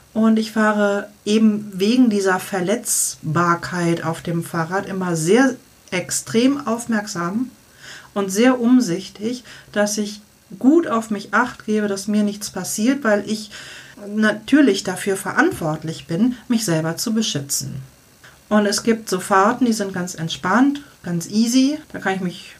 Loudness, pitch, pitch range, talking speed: -19 LUFS, 205 Hz, 180-225 Hz, 140 wpm